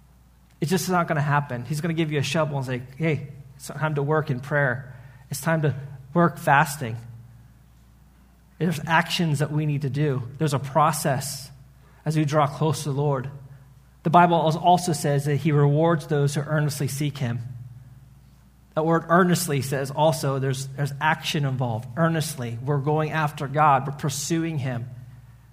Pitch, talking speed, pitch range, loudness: 145 Hz, 175 wpm, 130-155 Hz, -24 LUFS